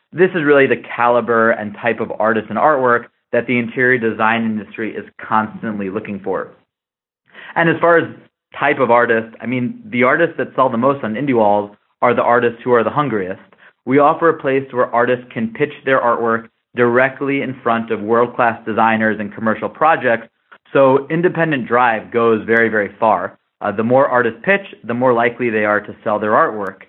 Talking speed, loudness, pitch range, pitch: 190 wpm, -16 LUFS, 110-130 Hz, 120 Hz